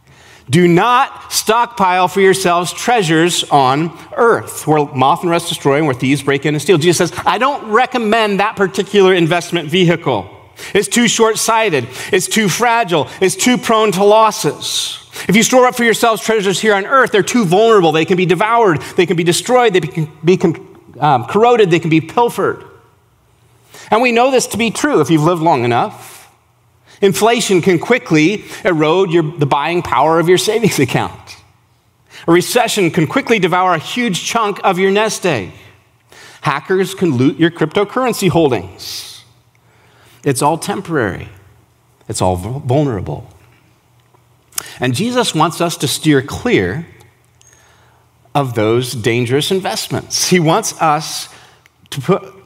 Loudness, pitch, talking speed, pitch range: -13 LUFS, 170 Hz, 155 wpm, 130-200 Hz